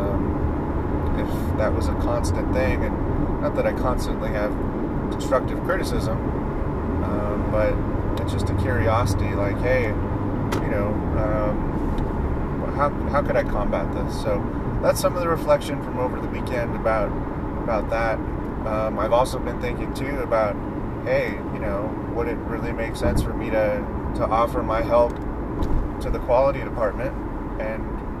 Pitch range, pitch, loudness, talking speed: 80-105 Hz, 100 Hz, -24 LUFS, 150 wpm